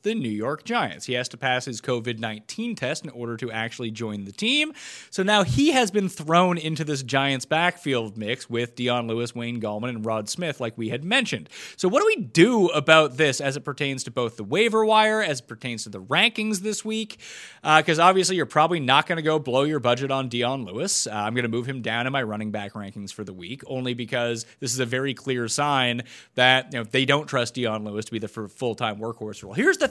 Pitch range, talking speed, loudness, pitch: 115-160 Hz, 245 wpm, -23 LUFS, 130 Hz